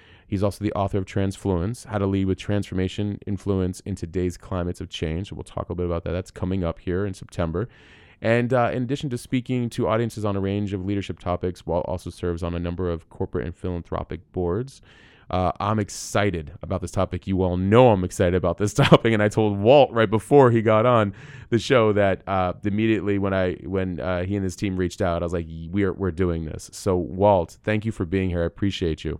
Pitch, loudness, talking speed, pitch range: 95 Hz, -23 LUFS, 230 wpm, 90-105 Hz